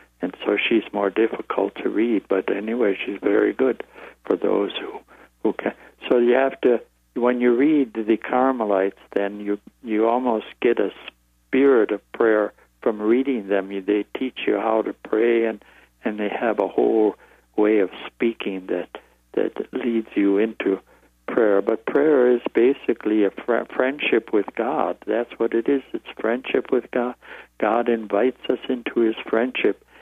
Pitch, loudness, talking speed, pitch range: 115 Hz, -22 LUFS, 165 wpm, 100-125 Hz